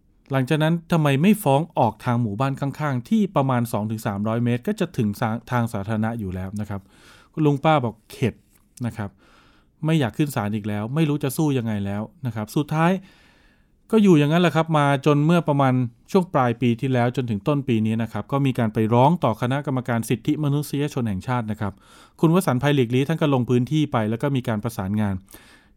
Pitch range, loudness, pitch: 110-150 Hz, -22 LUFS, 125 Hz